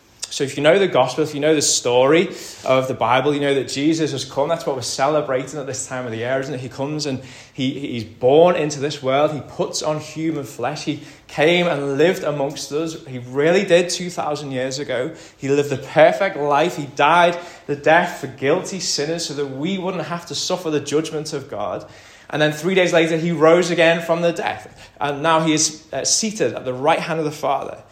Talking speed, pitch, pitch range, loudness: 225 wpm, 150 Hz, 135-165 Hz, -19 LUFS